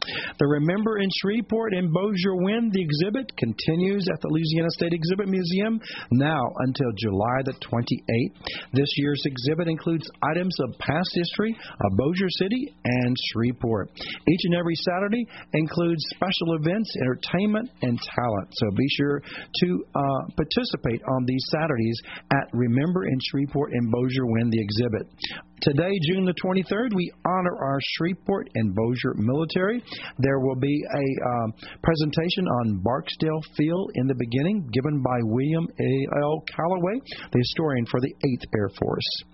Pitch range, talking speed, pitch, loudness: 130-185 Hz, 150 wpm, 155 Hz, -25 LUFS